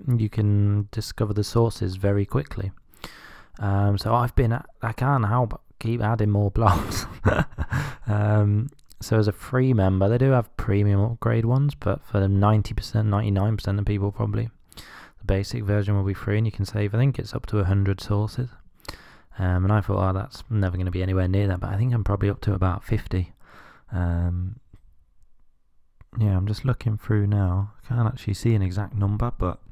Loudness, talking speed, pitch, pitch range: -24 LUFS, 190 wpm, 105 Hz, 100-115 Hz